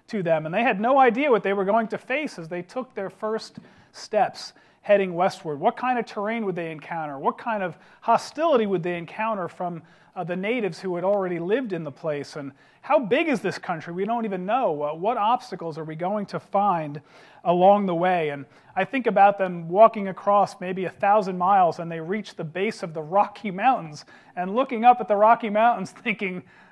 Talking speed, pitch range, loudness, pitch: 215 wpm, 175-220 Hz, -24 LUFS, 195 Hz